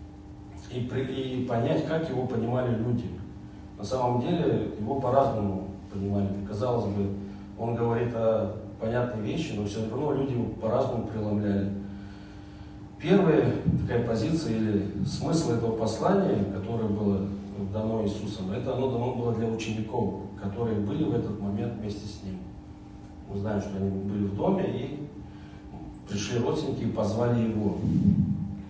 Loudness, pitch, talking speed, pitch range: -28 LUFS, 105 Hz, 135 wpm, 100-120 Hz